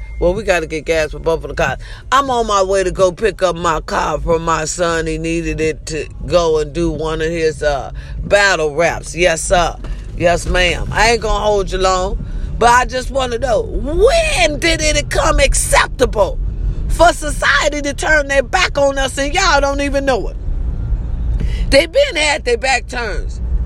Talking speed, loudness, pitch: 200 wpm, -15 LUFS, 185 Hz